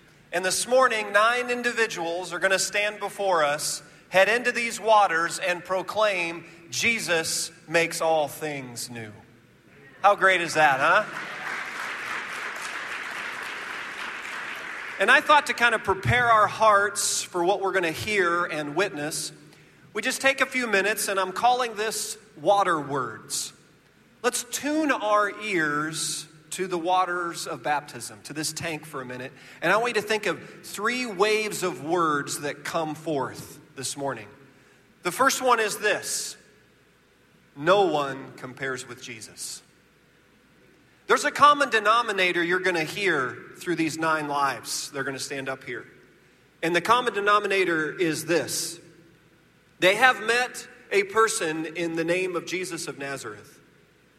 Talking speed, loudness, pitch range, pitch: 145 wpm, -24 LUFS, 155-210 Hz, 175 Hz